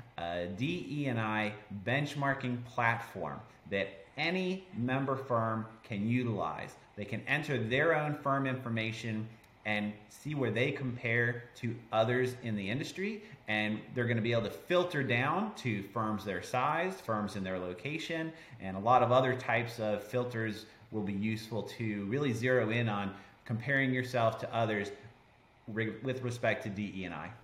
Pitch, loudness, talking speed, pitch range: 115 Hz, -34 LUFS, 150 wpm, 105-130 Hz